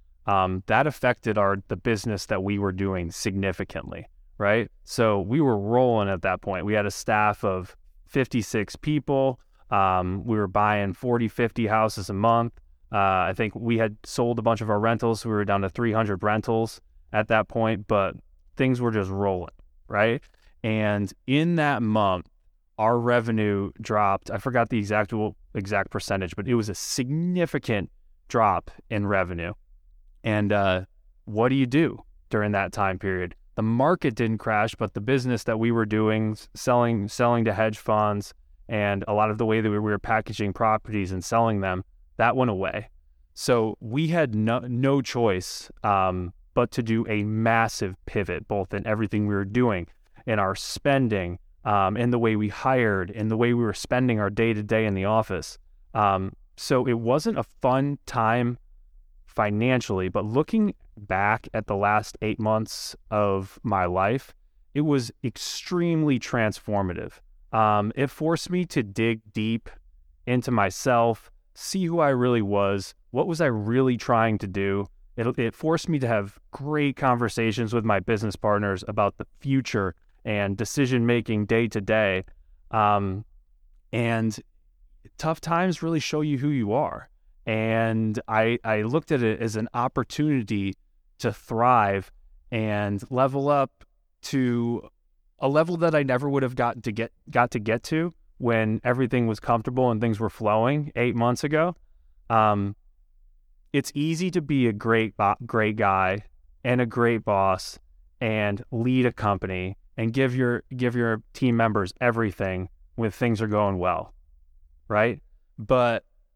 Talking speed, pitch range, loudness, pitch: 160 wpm, 100-120 Hz, -25 LUFS, 110 Hz